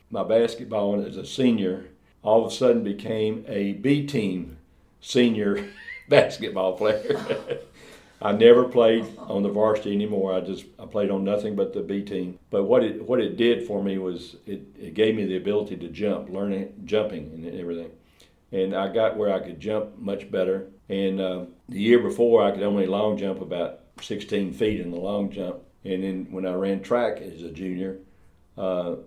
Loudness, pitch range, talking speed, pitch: -24 LUFS, 95-105 Hz, 190 wpm, 100 Hz